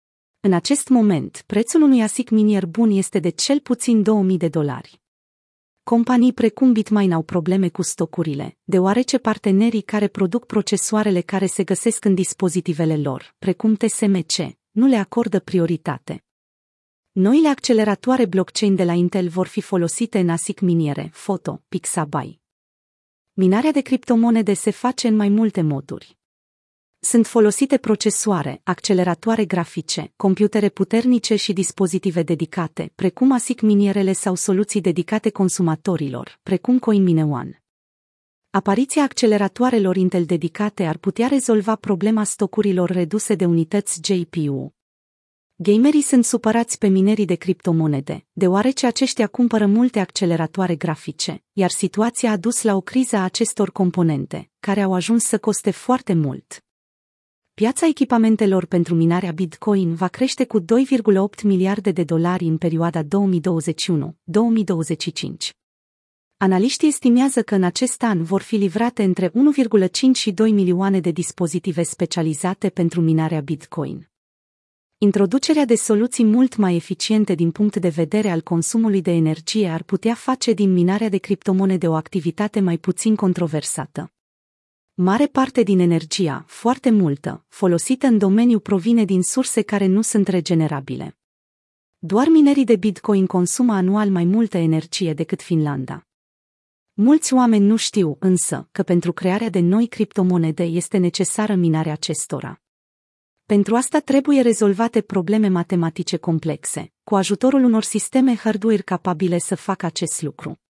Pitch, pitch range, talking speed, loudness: 195 Hz, 175-220 Hz, 135 wpm, -19 LUFS